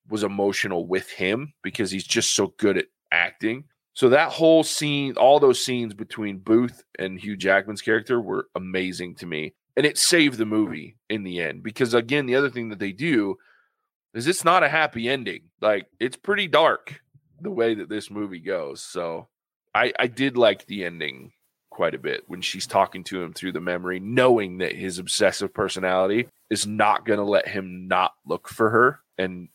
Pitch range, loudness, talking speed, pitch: 95-135 Hz, -23 LUFS, 190 wpm, 110 Hz